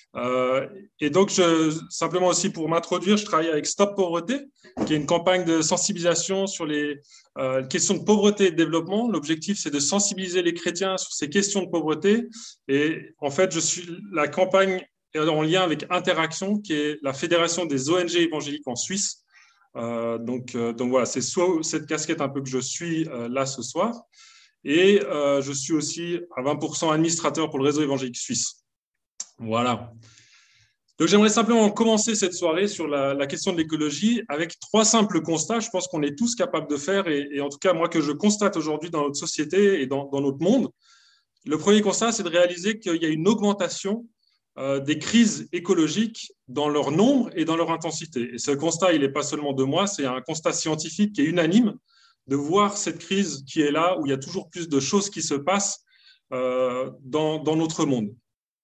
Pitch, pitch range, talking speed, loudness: 165 Hz, 145-195 Hz, 200 wpm, -23 LUFS